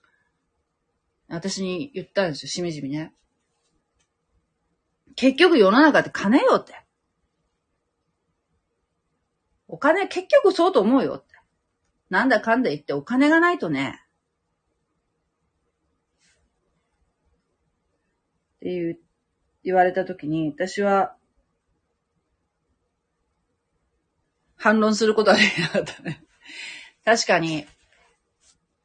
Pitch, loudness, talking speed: 160 Hz, -21 LUFS, 170 characters per minute